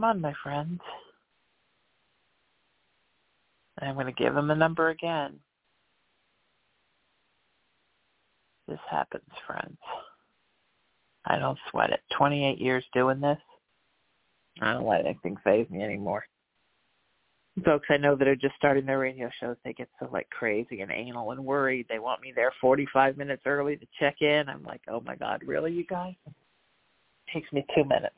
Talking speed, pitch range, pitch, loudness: 160 wpm, 135-150 Hz, 140 Hz, -28 LUFS